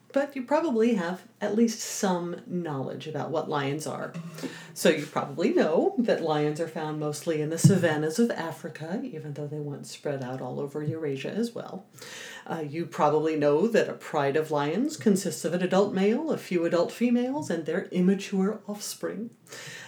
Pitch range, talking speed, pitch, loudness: 150-215 Hz, 180 wpm, 170 Hz, -28 LUFS